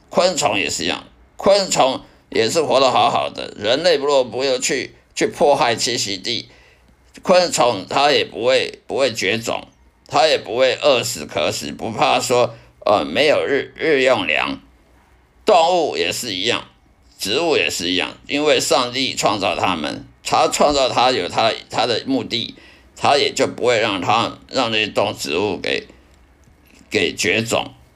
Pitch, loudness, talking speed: 150 Hz, -18 LUFS, 220 characters per minute